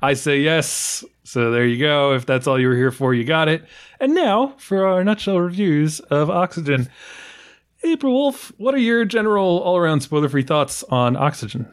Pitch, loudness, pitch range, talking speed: 155 Hz, -19 LUFS, 135-195 Hz, 195 wpm